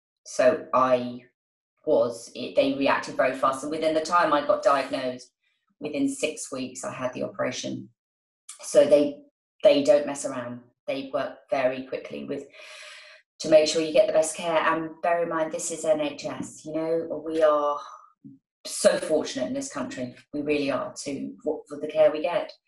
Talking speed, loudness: 175 wpm, -25 LUFS